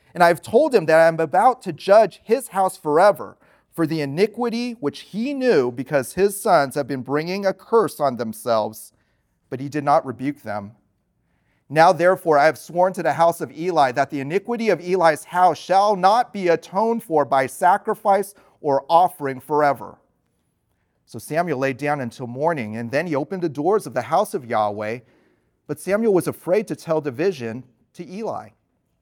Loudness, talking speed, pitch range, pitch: -20 LUFS, 180 wpm, 135-190 Hz, 160 Hz